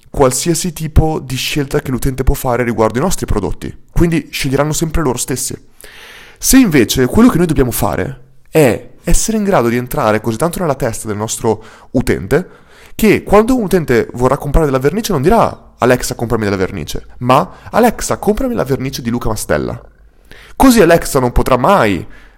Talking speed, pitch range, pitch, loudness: 170 wpm, 120-170 Hz, 135 Hz, -14 LUFS